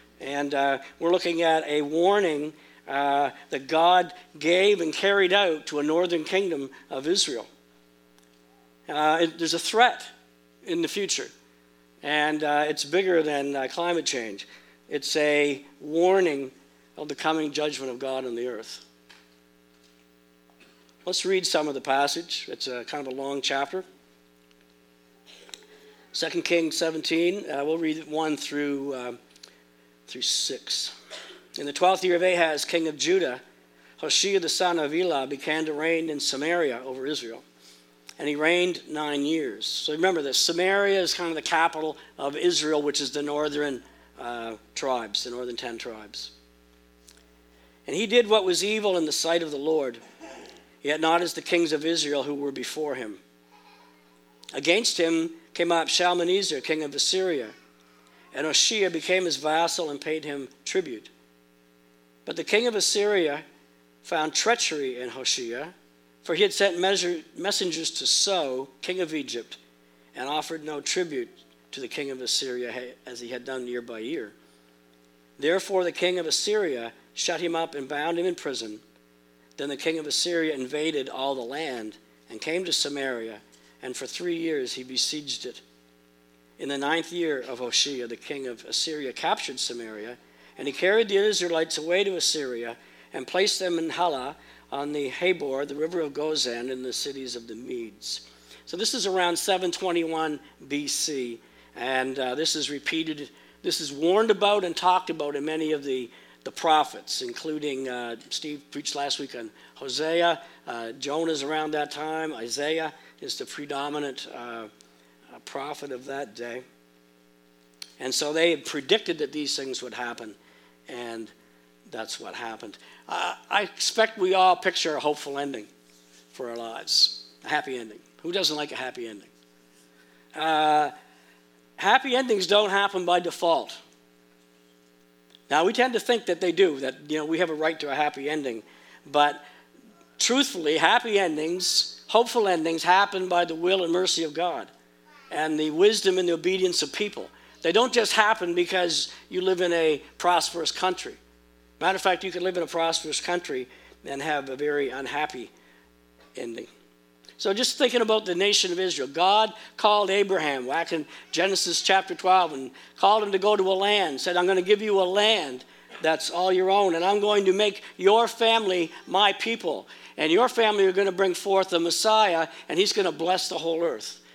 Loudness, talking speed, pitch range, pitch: -25 LUFS, 165 wpm, 115-180 Hz, 150 Hz